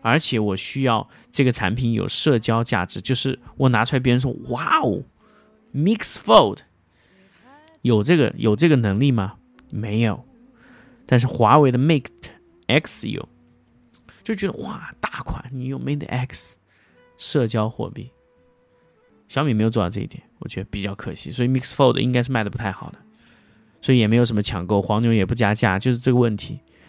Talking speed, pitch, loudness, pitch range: 280 characters per minute, 120 Hz, -21 LUFS, 105-135 Hz